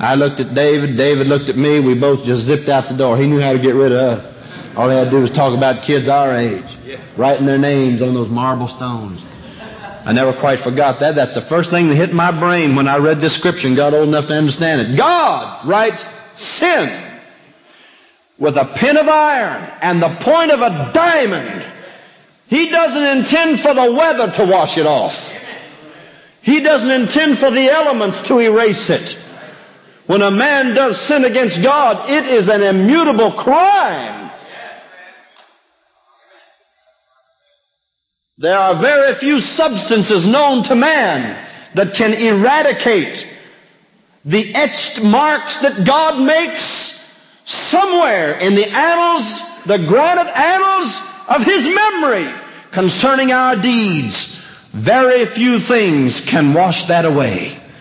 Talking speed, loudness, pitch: 155 wpm, -13 LUFS, 205 Hz